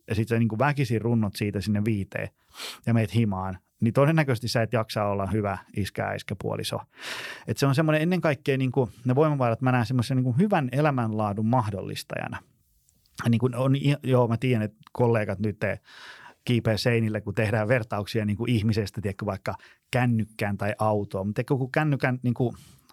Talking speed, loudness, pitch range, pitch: 165 wpm, -26 LUFS, 105-130 Hz, 115 Hz